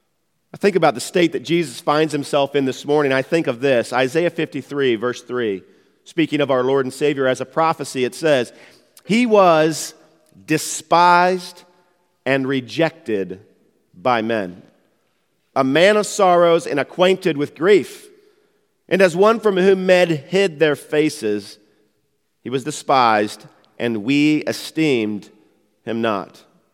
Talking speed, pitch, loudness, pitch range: 140 wpm, 155 Hz, -18 LUFS, 130-175 Hz